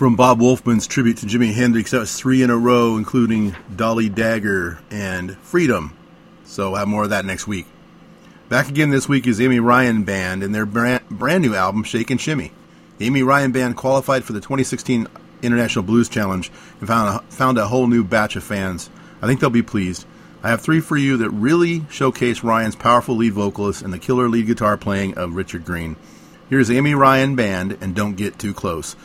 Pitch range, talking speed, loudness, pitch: 105-130 Hz, 205 wpm, -18 LUFS, 115 Hz